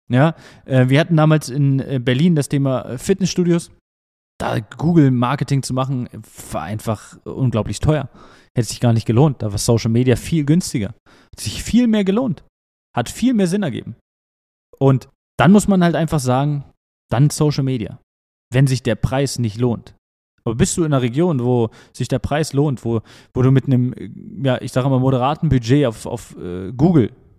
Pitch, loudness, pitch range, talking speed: 130 Hz, -18 LUFS, 115-150 Hz, 175 wpm